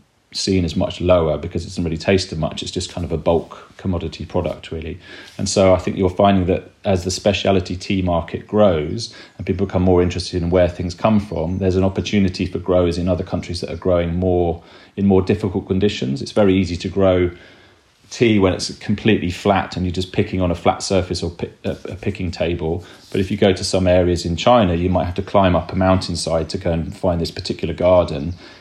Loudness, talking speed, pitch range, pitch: -19 LUFS, 220 wpm, 90-100 Hz, 90 Hz